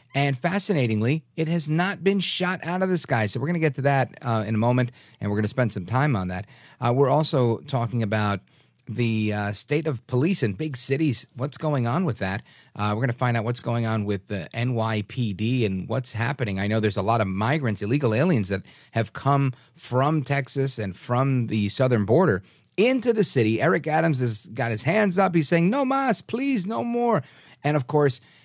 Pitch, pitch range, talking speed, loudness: 130 Hz, 110-155 Hz, 215 wpm, -24 LUFS